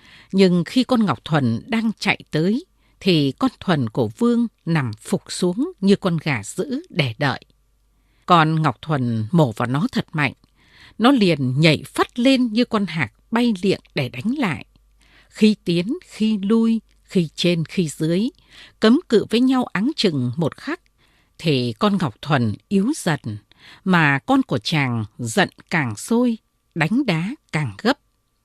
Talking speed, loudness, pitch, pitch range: 160 wpm, -20 LUFS, 175 Hz, 140-220 Hz